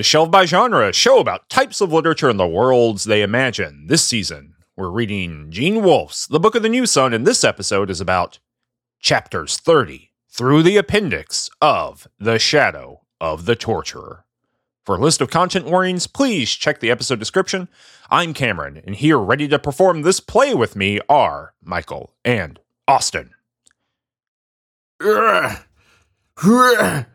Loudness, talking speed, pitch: -16 LUFS, 155 wpm, 130 Hz